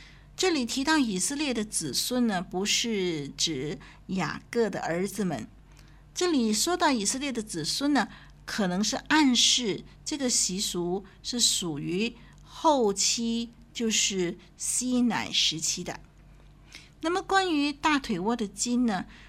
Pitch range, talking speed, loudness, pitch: 185-265 Hz, 195 characters per minute, -27 LUFS, 230 Hz